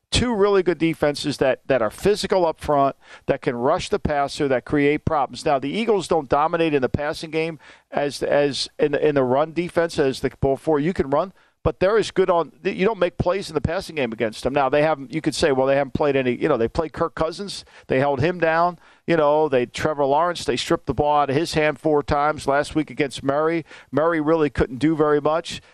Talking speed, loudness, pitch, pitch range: 240 wpm, -21 LUFS, 155 Hz, 145-165 Hz